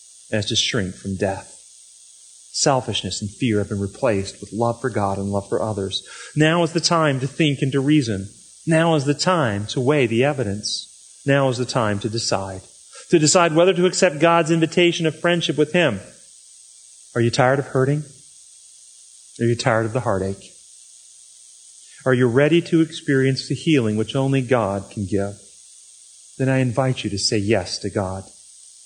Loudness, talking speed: -20 LUFS, 175 wpm